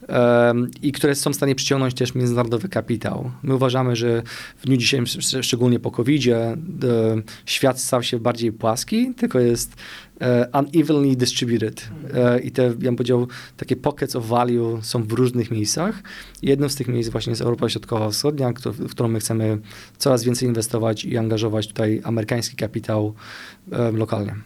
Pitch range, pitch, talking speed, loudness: 115-130 Hz, 120 Hz, 150 wpm, -21 LUFS